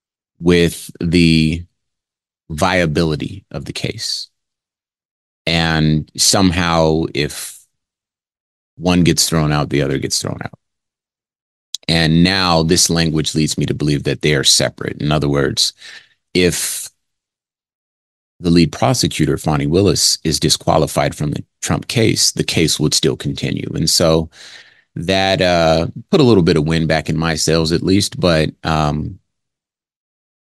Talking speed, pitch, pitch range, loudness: 135 wpm, 80 Hz, 75-85 Hz, -15 LUFS